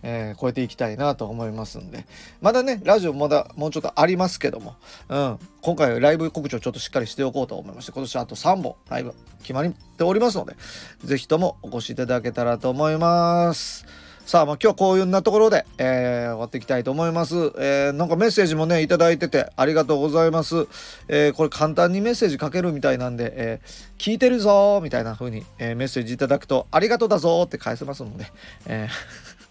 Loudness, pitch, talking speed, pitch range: -22 LUFS, 150 Hz, 465 characters per minute, 125-170 Hz